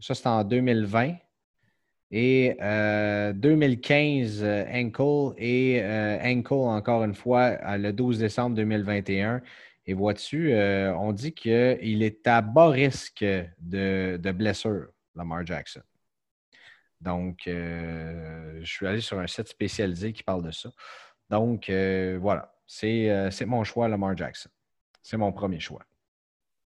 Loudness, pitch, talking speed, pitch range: -26 LUFS, 105 Hz, 140 wpm, 95-120 Hz